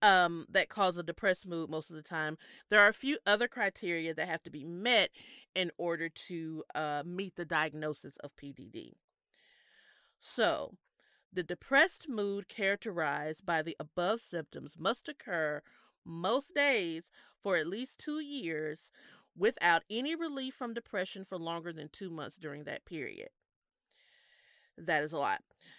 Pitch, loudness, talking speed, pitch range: 175 Hz, -34 LUFS, 150 wpm, 160-220 Hz